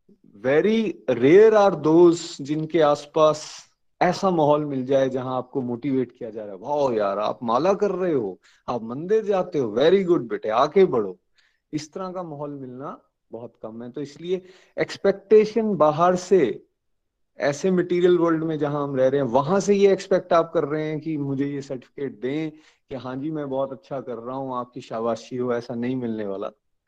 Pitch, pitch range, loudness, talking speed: 155 Hz, 135-185 Hz, -22 LUFS, 190 wpm